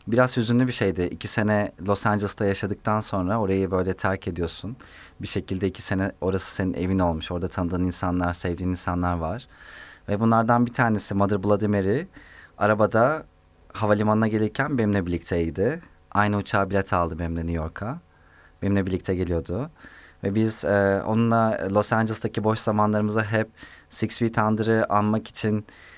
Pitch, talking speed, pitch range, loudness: 100 Hz, 145 wpm, 90-110 Hz, -24 LUFS